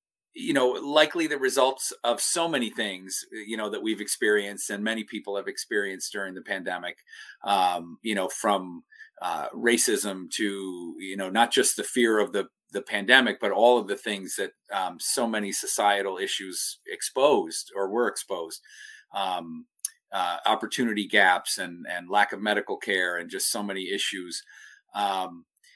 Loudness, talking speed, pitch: -26 LUFS, 165 wpm, 125 Hz